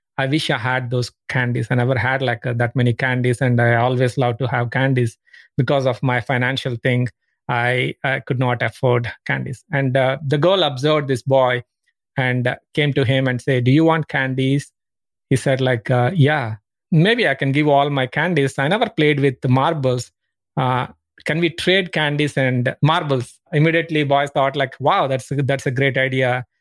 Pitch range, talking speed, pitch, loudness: 125-145 Hz, 190 wpm, 135 Hz, -19 LUFS